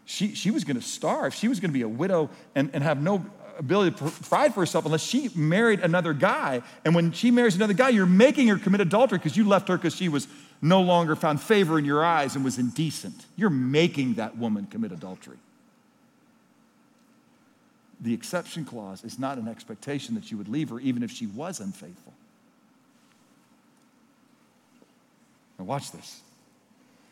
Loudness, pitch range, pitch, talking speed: -25 LUFS, 160-250 Hz, 210 Hz, 180 wpm